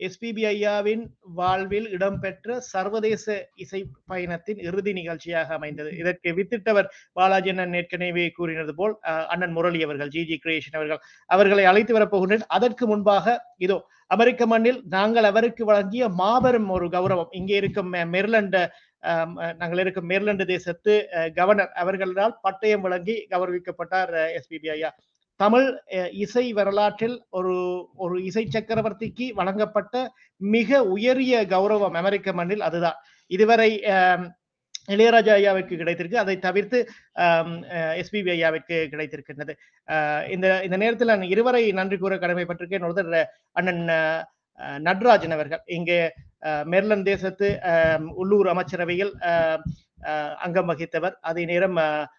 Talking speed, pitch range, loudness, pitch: 110 wpm, 170-210 Hz, -23 LUFS, 185 Hz